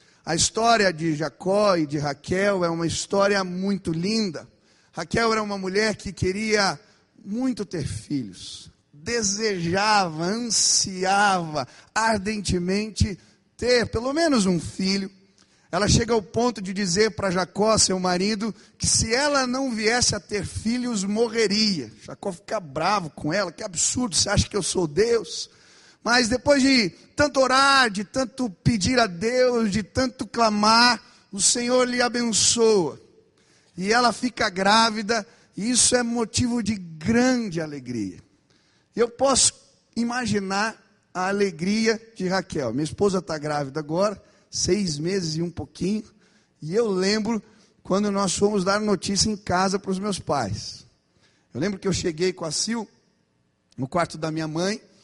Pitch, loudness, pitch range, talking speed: 205 Hz, -23 LUFS, 180-230 Hz, 145 wpm